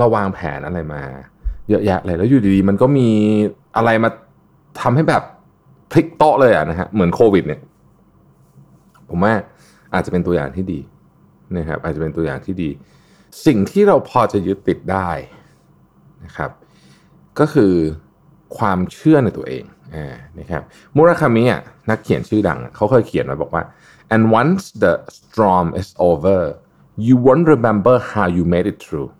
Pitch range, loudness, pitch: 85-120 Hz, -16 LUFS, 100 Hz